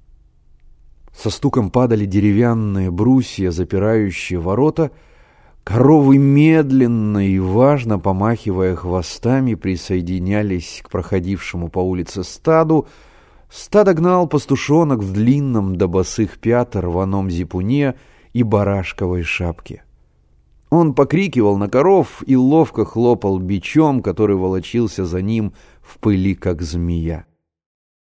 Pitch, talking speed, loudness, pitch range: 100 Hz, 105 wpm, -17 LUFS, 90-130 Hz